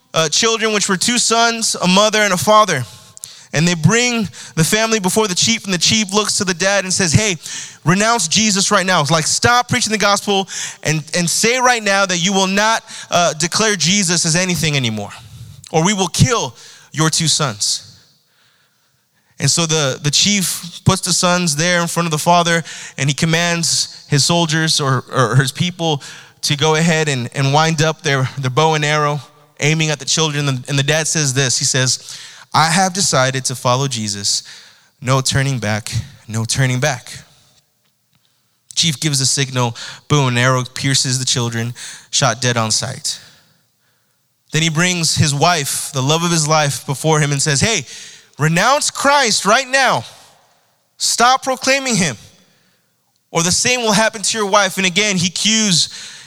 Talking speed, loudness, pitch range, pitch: 180 wpm, -15 LUFS, 135-190 Hz, 160 Hz